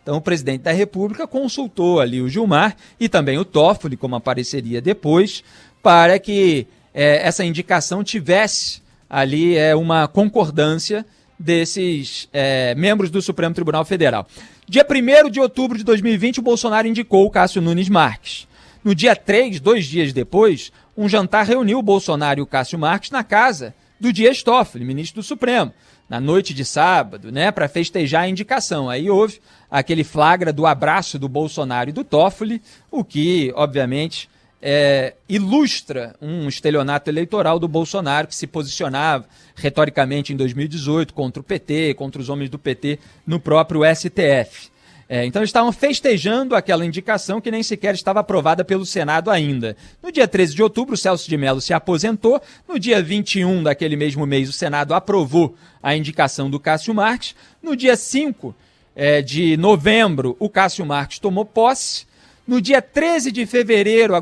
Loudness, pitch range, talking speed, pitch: -17 LUFS, 150-215 Hz, 160 wpm, 175 Hz